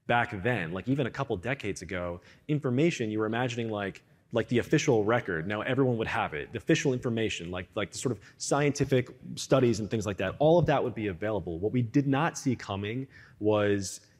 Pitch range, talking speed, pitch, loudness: 105-135 Hz, 205 wpm, 120 Hz, -29 LUFS